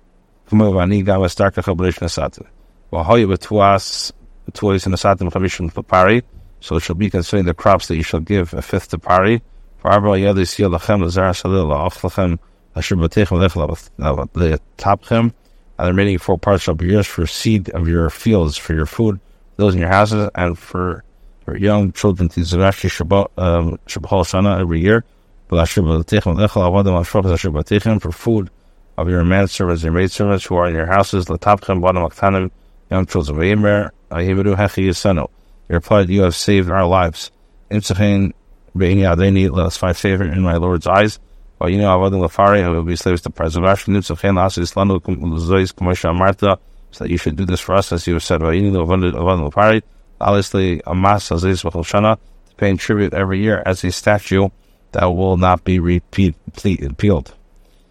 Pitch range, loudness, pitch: 85-100 Hz, -16 LUFS, 95 Hz